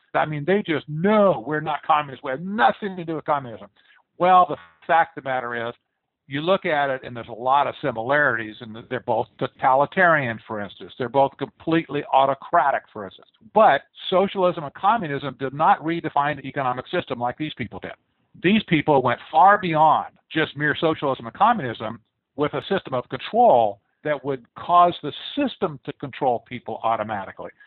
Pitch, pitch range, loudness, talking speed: 145 Hz, 125-165 Hz, -22 LUFS, 180 wpm